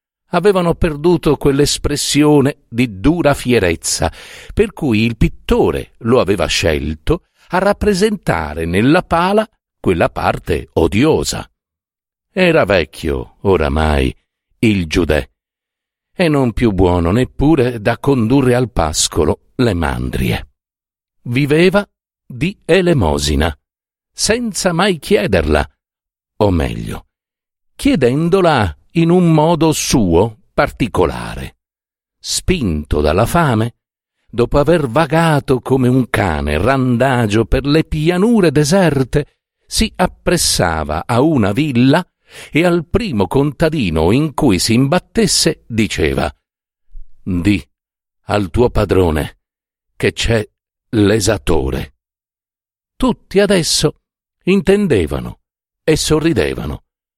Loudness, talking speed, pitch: -15 LUFS, 95 wpm, 125 Hz